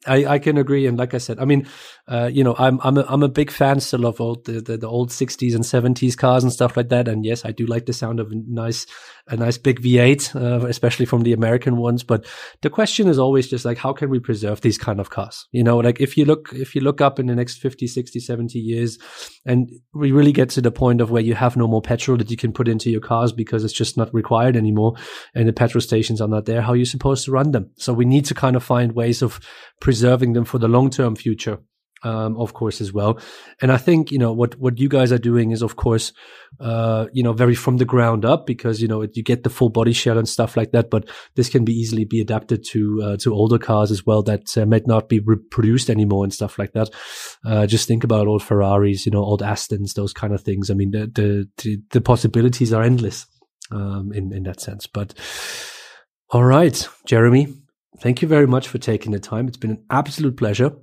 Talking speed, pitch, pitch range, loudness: 250 wpm, 120 Hz, 110-130 Hz, -19 LUFS